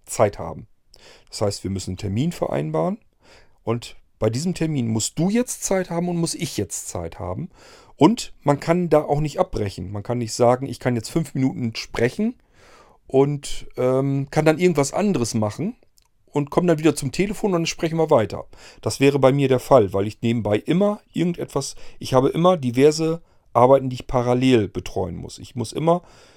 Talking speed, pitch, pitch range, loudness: 190 wpm, 135 Hz, 115-165 Hz, -21 LUFS